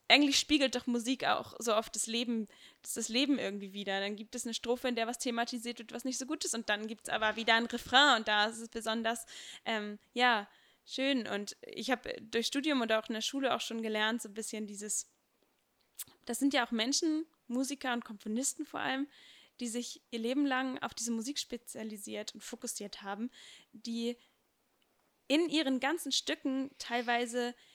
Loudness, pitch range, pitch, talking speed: -34 LUFS, 225-265 Hz, 240 Hz, 195 wpm